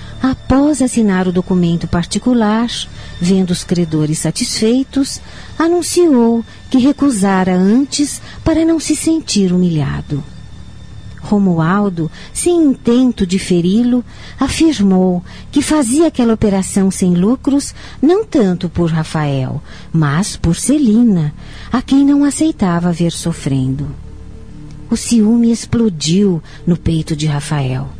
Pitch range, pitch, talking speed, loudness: 170-265 Hz, 205 Hz, 105 wpm, -14 LUFS